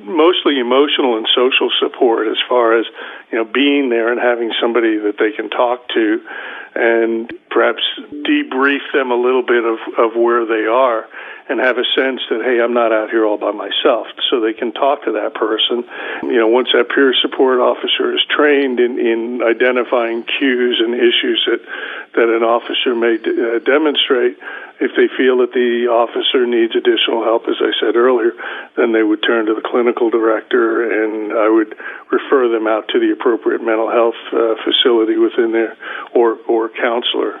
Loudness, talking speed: -15 LUFS, 180 wpm